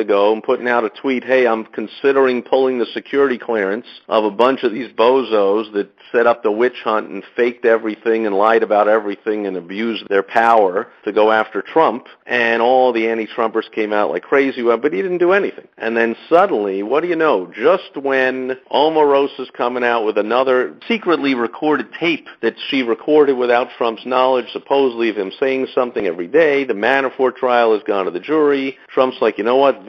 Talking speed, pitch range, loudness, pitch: 195 wpm, 110-135 Hz, -17 LUFS, 120 Hz